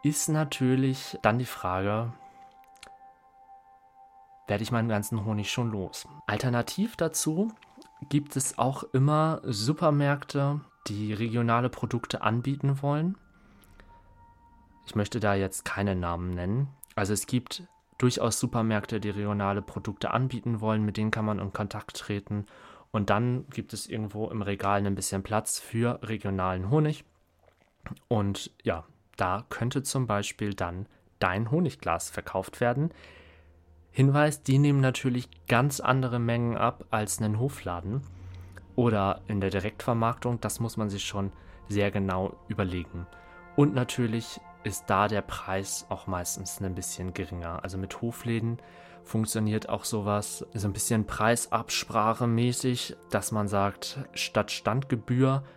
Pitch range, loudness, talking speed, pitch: 100-130 Hz, -29 LUFS, 130 wpm, 110 Hz